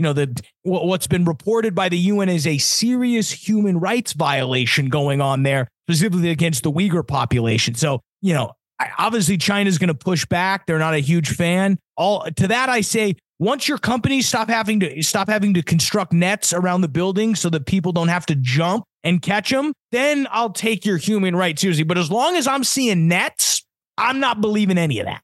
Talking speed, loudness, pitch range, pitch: 205 wpm, -19 LUFS, 160-215 Hz, 185 Hz